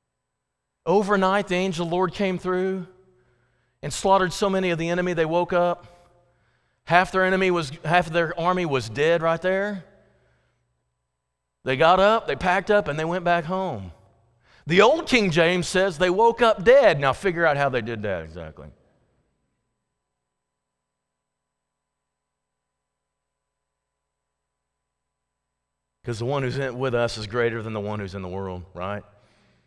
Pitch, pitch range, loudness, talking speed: 150 Hz, 110-185 Hz, -22 LUFS, 150 wpm